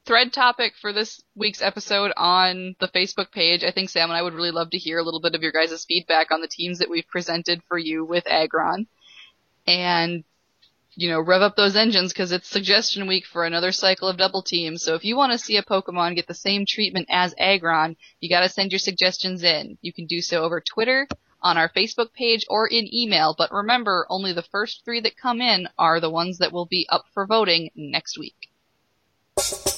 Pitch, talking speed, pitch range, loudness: 185 Hz, 215 wpm, 170-205 Hz, -21 LUFS